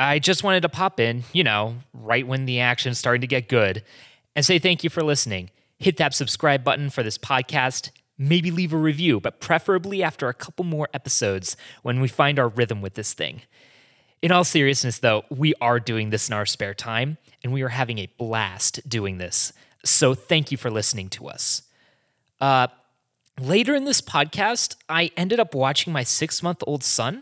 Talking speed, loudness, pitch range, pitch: 200 wpm, -22 LUFS, 120-160 Hz, 130 Hz